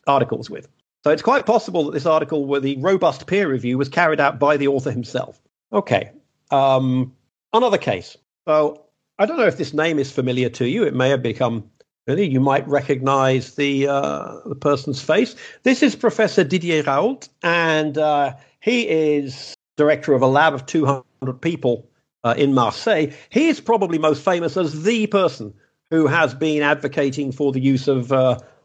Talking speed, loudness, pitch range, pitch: 180 wpm, -19 LUFS, 135-160 Hz, 145 Hz